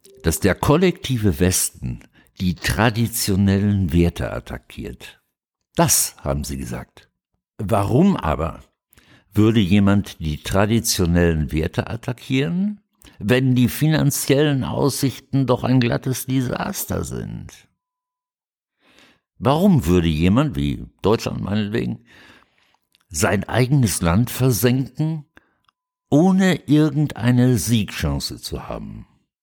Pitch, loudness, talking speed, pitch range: 115 Hz, -19 LUFS, 90 wpm, 95-140 Hz